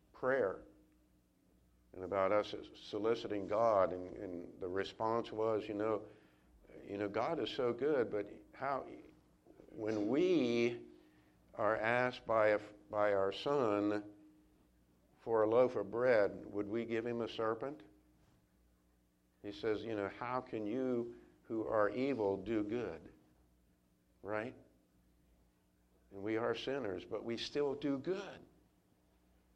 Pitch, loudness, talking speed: 105 Hz, -37 LUFS, 130 wpm